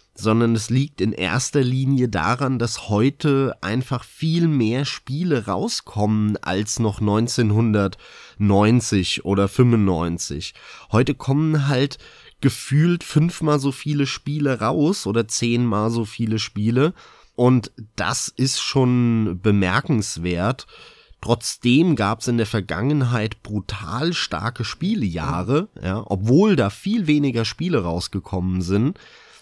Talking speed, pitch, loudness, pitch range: 110 wpm, 115 Hz, -21 LUFS, 105-135 Hz